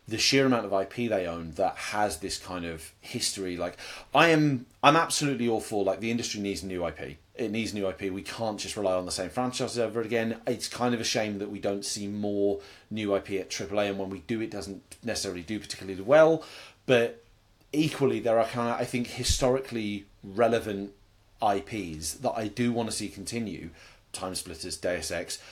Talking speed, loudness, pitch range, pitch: 200 wpm, -28 LUFS, 95-120 Hz, 105 Hz